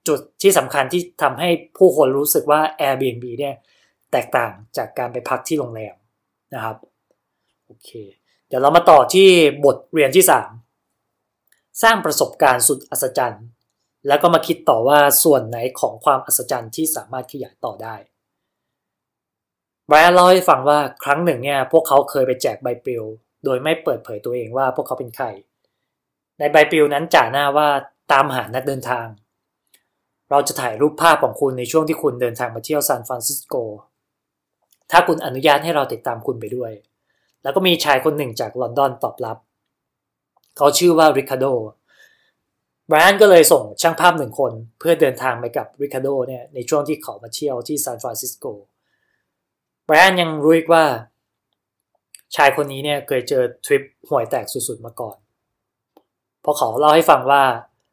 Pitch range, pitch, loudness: 125-155 Hz, 140 Hz, -16 LUFS